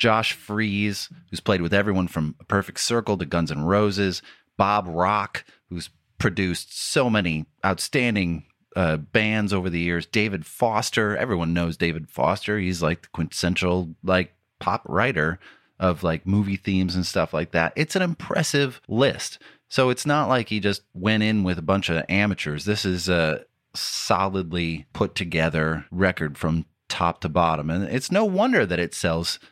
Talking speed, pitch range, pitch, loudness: 160 wpm, 85-105 Hz, 95 Hz, -24 LUFS